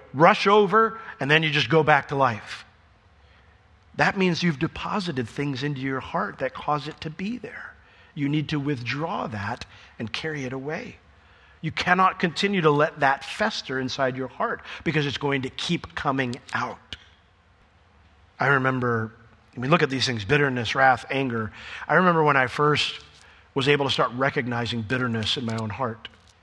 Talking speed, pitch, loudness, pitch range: 175 wpm, 135 Hz, -24 LUFS, 115-155 Hz